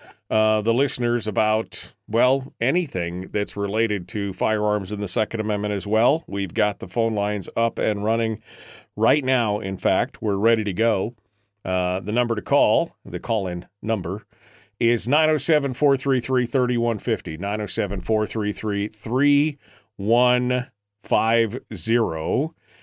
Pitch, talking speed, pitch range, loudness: 110 Hz, 115 wpm, 105-120 Hz, -23 LUFS